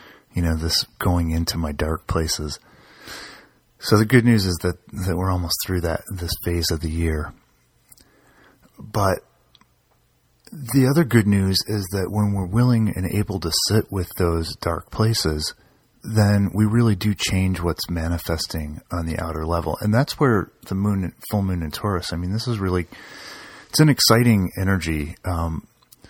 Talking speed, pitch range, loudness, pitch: 165 wpm, 85-105 Hz, -21 LUFS, 95 Hz